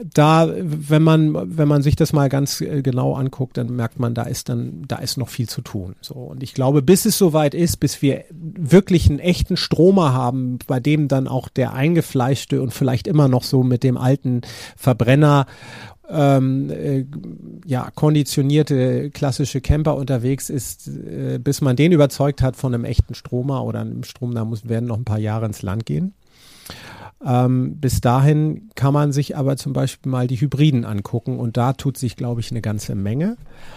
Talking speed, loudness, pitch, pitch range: 185 wpm, -19 LUFS, 135 Hz, 125-150 Hz